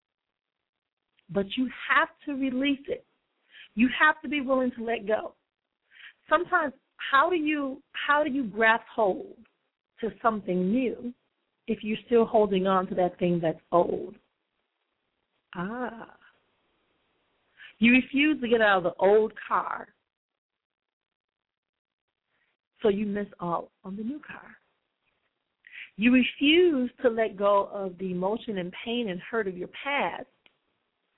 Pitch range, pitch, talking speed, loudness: 200-270 Hz, 230 Hz, 135 wpm, -26 LUFS